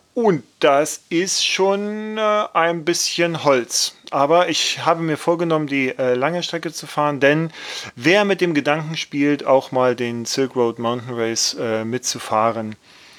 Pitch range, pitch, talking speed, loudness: 125-170 Hz, 150 Hz, 140 wpm, -19 LUFS